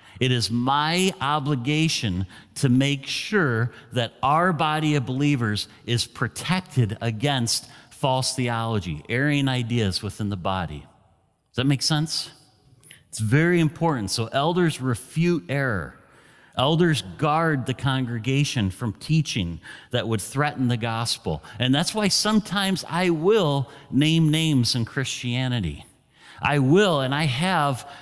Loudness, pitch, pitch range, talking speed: -23 LUFS, 135 Hz, 115-155 Hz, 125 wpm